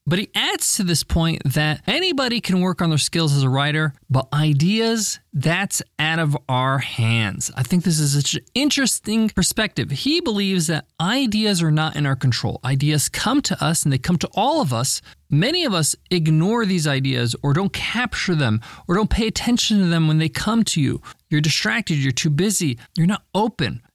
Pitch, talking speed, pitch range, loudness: 165 Hz, 200 wpm, 145-205 Hz, -20 LUFS